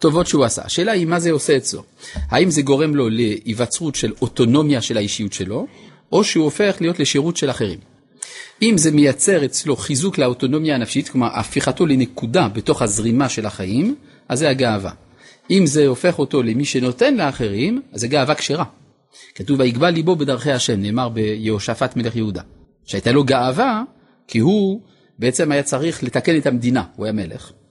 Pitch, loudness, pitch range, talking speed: 135 Hz, -18 LUFS, 115-155 Hz, 165 wpm